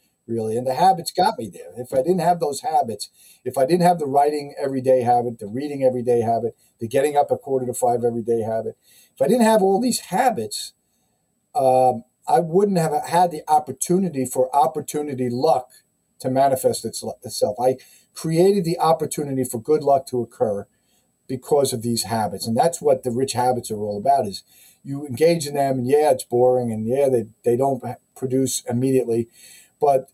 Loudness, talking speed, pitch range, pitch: -21 LUFS, 185 wpm, 125-165 Hz, 135 Hz